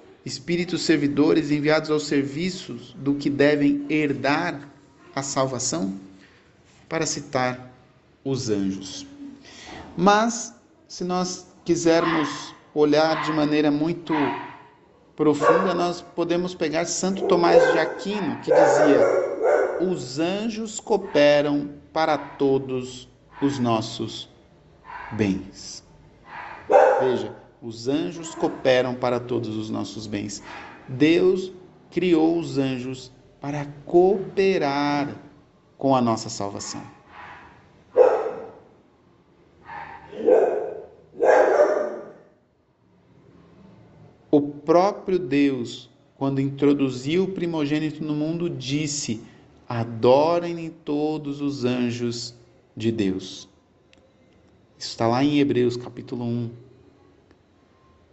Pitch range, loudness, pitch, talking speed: 125-170 Hz, -23 LUFS, 145 Hz, 85 wpm